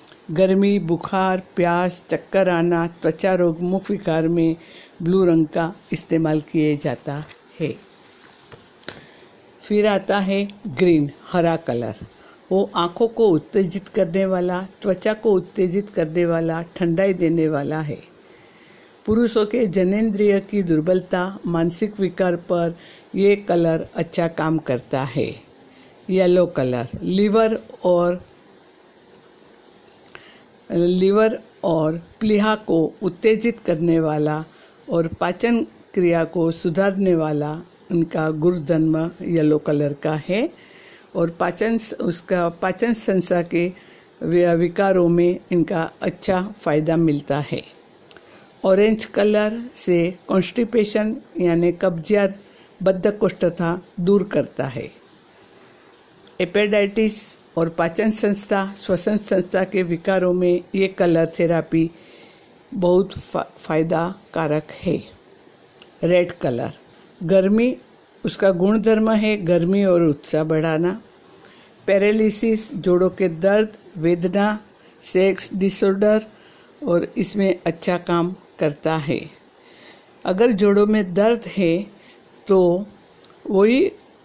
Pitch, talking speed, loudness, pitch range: 180 Hz, 100 wpm, -20 LUFS, 170-200 Hz